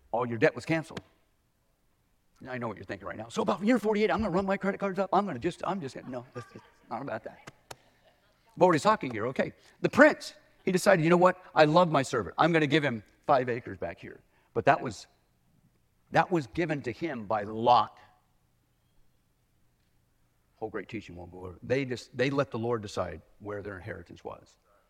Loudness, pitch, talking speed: -28 LUFS, 135 Hz, 210 wpm